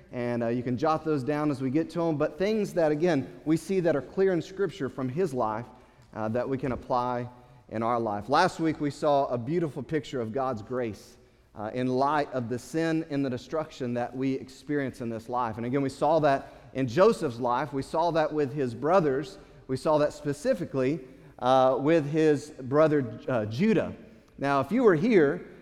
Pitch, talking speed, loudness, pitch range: 135 Hz, 205 wpm, -27 LUFS, 125-155 Hz